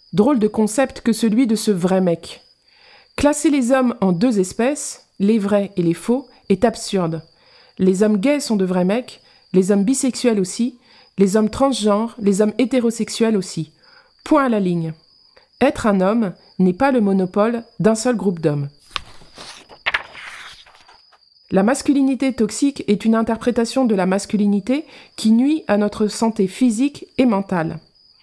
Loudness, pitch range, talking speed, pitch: -18 LUFS, 195-255 Hz, 155 wpm, 220 Hz